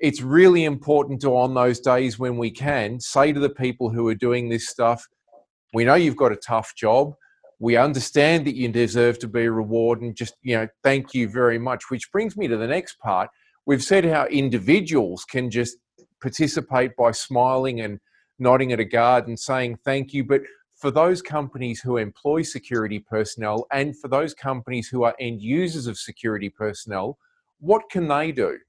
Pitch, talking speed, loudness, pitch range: 125 Hz, 185 wpm, -22 LUFS, 120-140 Hz